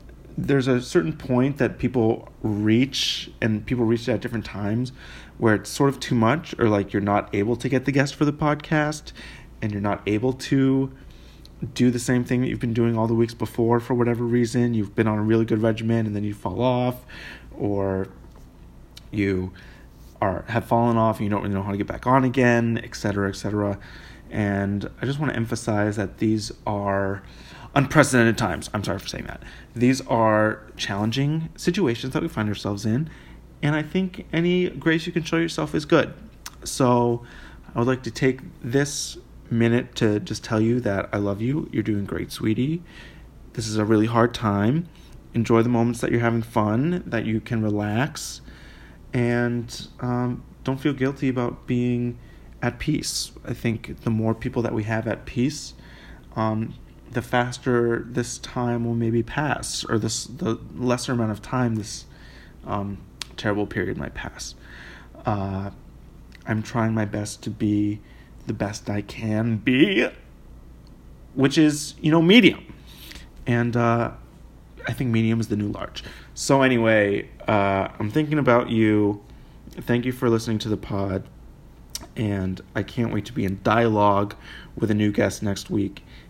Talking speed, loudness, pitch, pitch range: 175 wpm, -23 LUFS, 115 Hz, 105-125 Hz